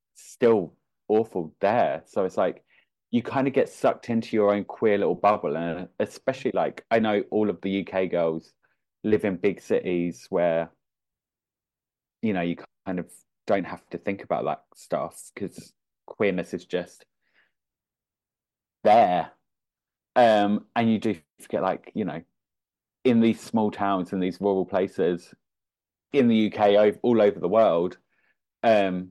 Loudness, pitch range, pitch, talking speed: -25 LUFS, 90-110 Hz, 100 Hz, 150 wpm